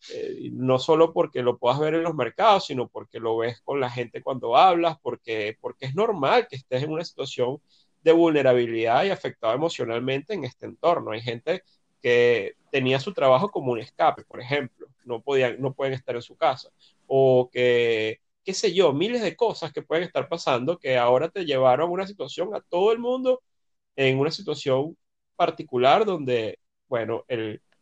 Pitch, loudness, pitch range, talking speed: 135 Hz, -24 LUFS, 125-170 Hz, 185 wpm